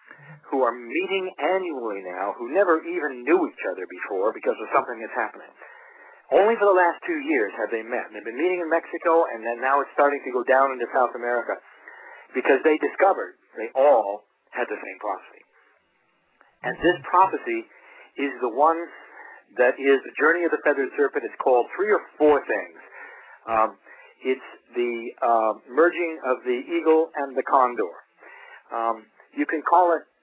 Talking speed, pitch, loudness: 175 wpm, 170 Hz, -23 LUFS